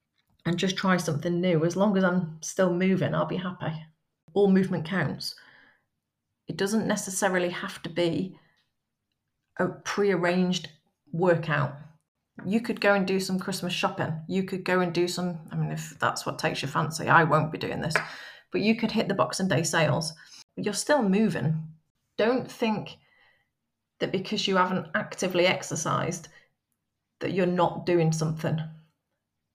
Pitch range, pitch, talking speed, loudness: 160-190 Hz, 175 Hz, 160 wpm, -27 LUFS